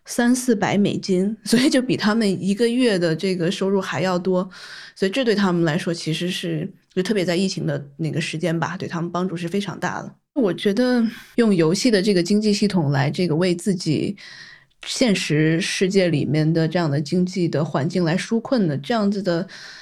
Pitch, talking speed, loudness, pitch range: 185 Hz, 295 characters per minute, -21 LUFS, 170-205 Hz